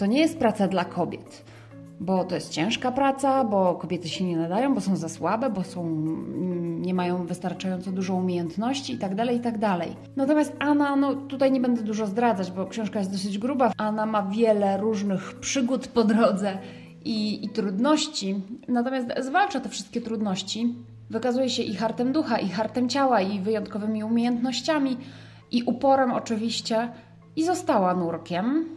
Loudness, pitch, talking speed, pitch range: -25 LUFS, 220 Hz, 155 wpm, 190-255 Hz